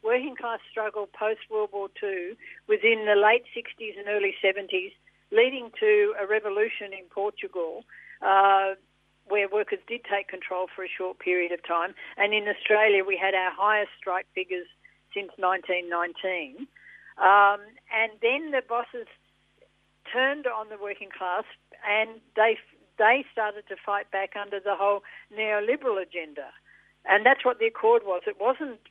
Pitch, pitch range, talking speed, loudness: 210 Hz, 195-235 Hz, 150 wpm, -26 LUFS